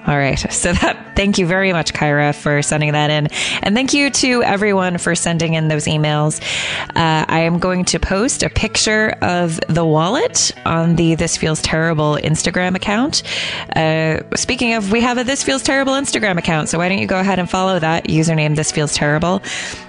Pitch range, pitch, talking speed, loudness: 155-200 Hz, 170 Hz, 195 wpm, -16 LUFS